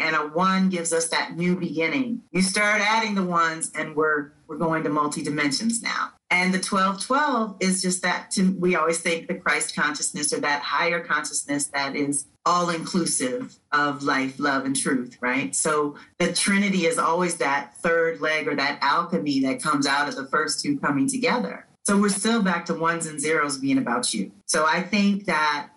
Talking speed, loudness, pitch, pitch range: 195 wpm, -23 LUFS, 165 Hz, 150-190 Hz